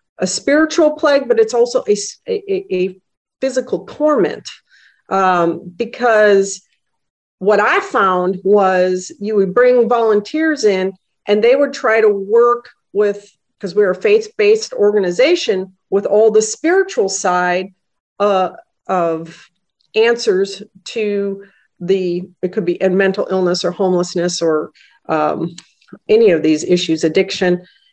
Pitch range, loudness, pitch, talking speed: 185-260 Hz, -15 LUFS, 205 Hz, 125 wpm